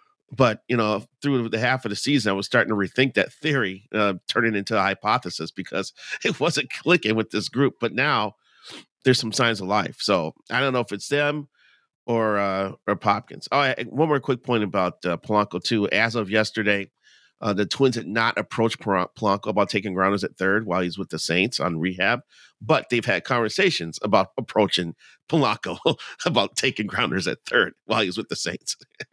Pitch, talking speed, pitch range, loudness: 110 Hz, 195 wpm, 100-125 Hz, -23 LUFS